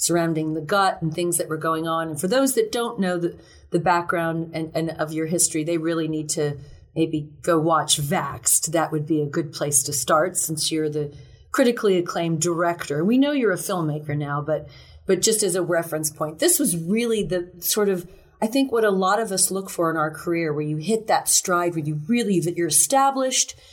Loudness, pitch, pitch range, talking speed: -22 LUFS, 170 Hz, 155-190 Hz, 220 wpm